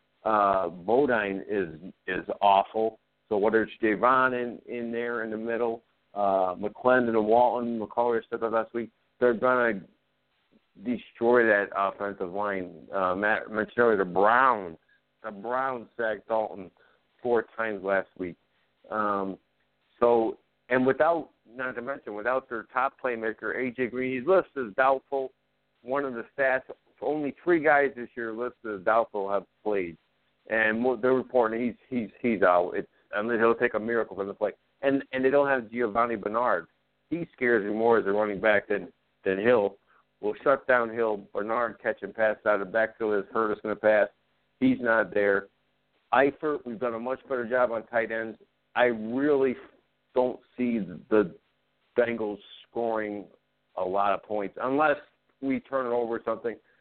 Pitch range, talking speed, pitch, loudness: 105-125 Hz, 170 wpm, 115 Hz, -27 LUFS